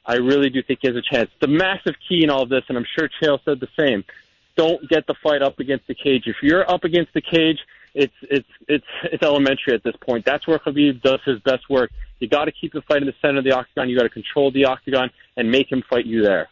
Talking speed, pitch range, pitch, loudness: 260 wpm, 130-155 Hz, 140 Hz, -20 LUFS